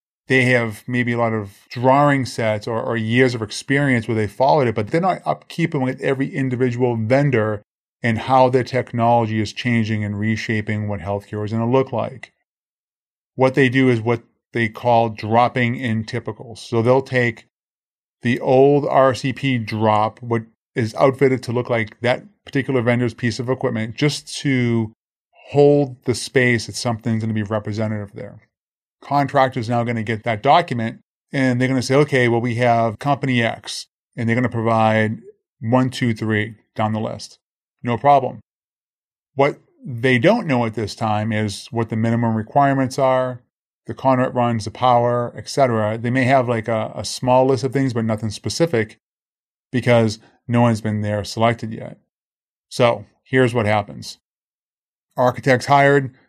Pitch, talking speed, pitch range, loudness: 120 Hz, 170 wpm, 110-130 Hz, -19 LUFS